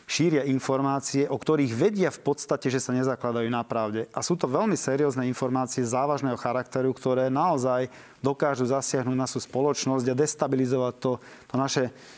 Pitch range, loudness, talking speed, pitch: 125-140 Hz, -26 LUFS, 160 wpm, 130 Hz